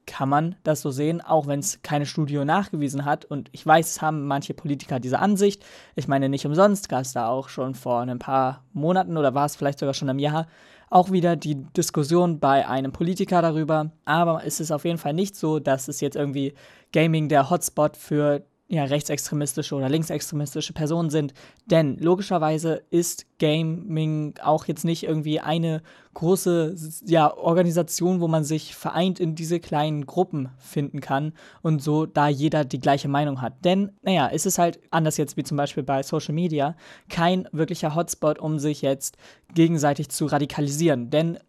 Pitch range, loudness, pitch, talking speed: 145-170 Hz, -24 LUFS, 155 Hz, 180 wpm